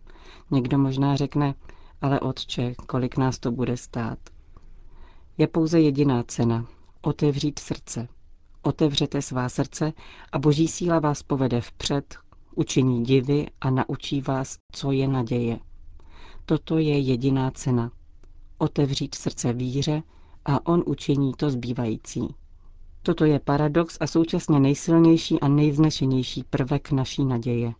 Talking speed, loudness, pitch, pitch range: 120 wpm, -24 LUFS, 140 Hz, 120-150 Hz